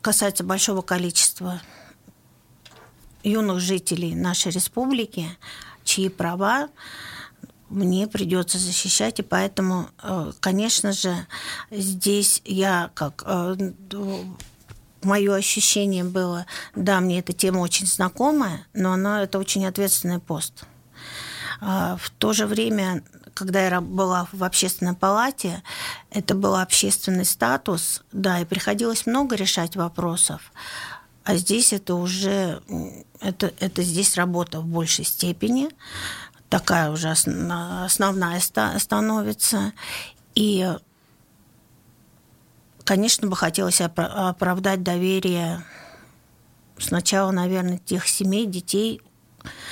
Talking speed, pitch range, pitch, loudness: 95 wpm, 180-200 Hz, 190 Hz, -22 LUFS